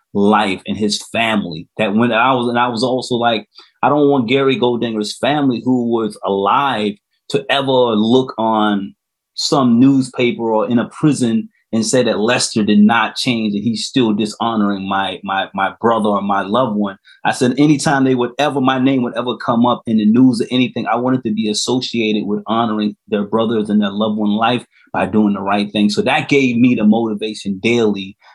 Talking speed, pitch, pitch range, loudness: 200 wpm, 115 Hz, 105-125 Hz, -16 LUFS